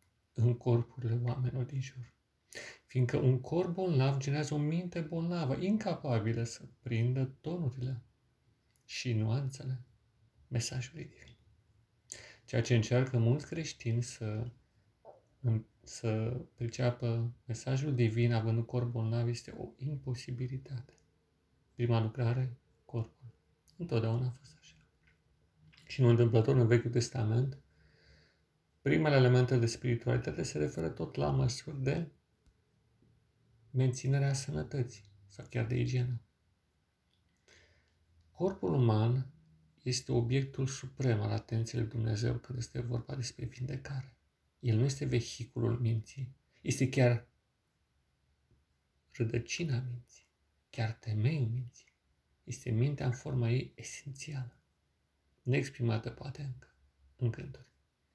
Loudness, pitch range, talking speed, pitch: -34 LUFS, 115-130 Hz, 105 wpm, 120 Hz